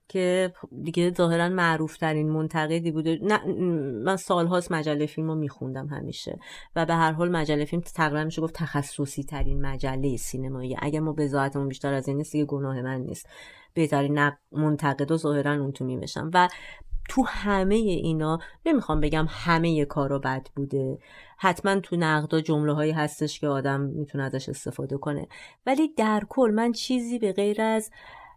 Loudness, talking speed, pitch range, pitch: -26 LUFS, 165 wpm, 140-175 Hz, 155 Hz